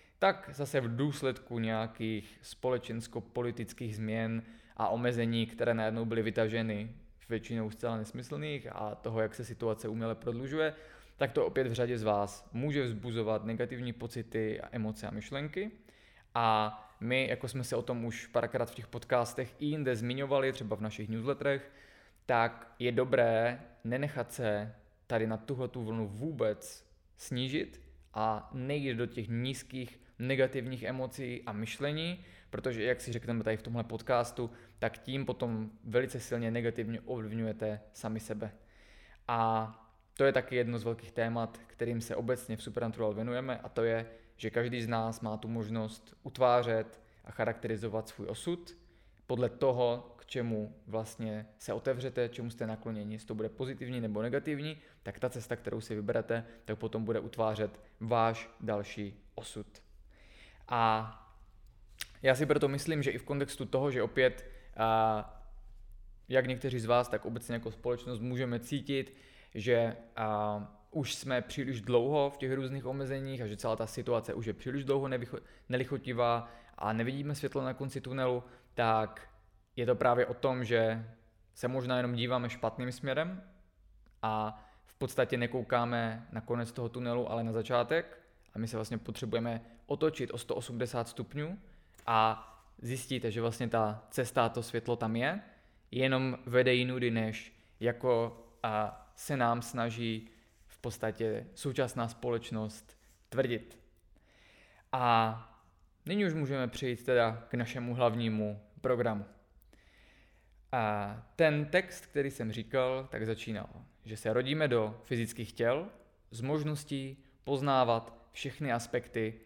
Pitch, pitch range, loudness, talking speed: 115 Hz, 110-125 Hz, -34 LUFS, 145 wpm